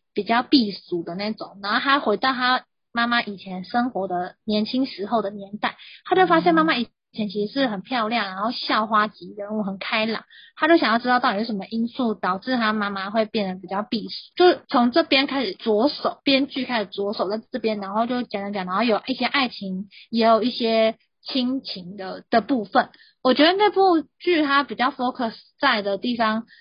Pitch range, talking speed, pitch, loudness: 205-260 Hz, 305 characters per minute, 230 Hz, -22 LUFS